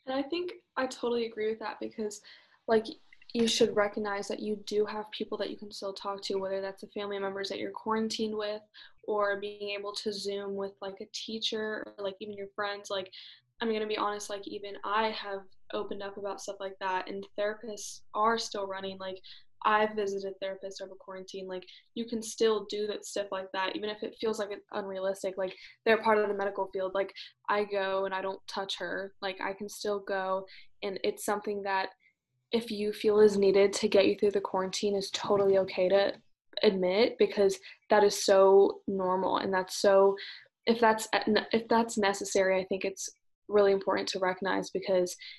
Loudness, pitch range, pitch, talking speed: -31 LUFS, 195-215 Hz, 205 Hz, 200 wpm